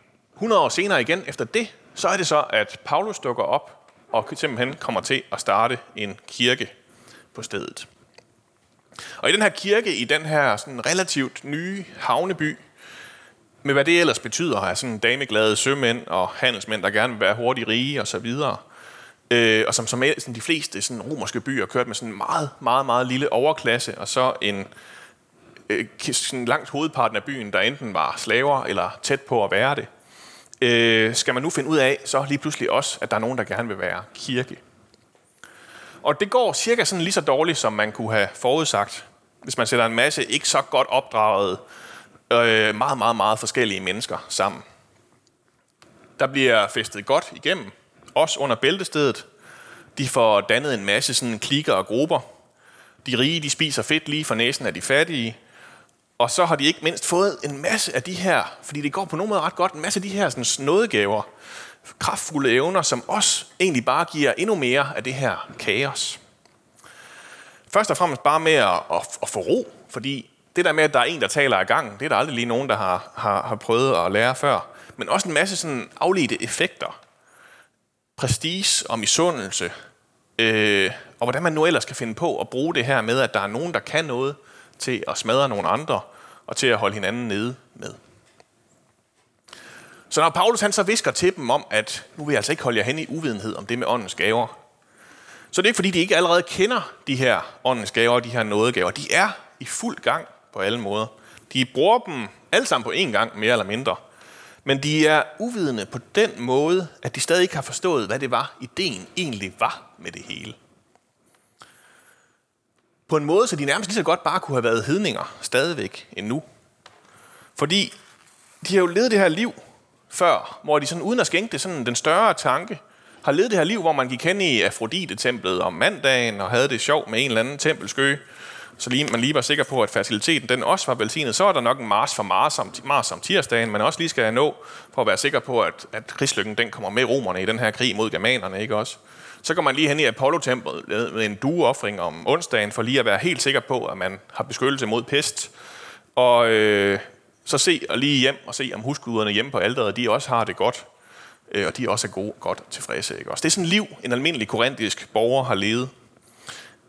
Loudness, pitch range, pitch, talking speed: -21 LUFS, 120-170 Hz, 135 Hz, 205 wpm